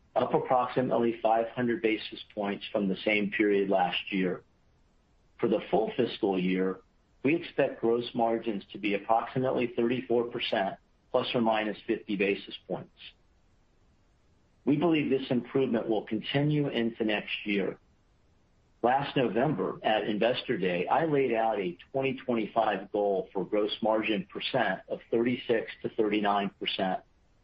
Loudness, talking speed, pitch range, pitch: -29 LUFS, 125 wpm, 100-120 Hz, 110 Hz